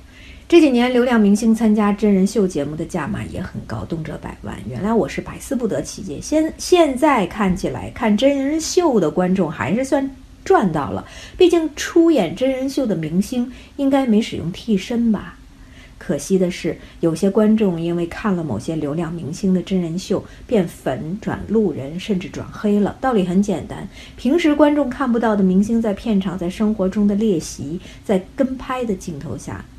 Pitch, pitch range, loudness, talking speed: 205 Hz, 180-255 Hz, -19 LUFS, 270 characters per minute